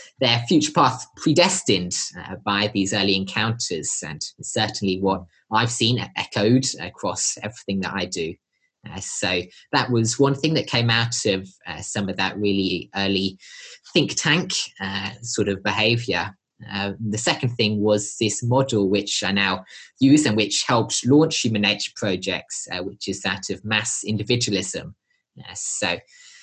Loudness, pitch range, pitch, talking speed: -22 LUFS, 100-120 Hz, 105 Hz, 155 wpm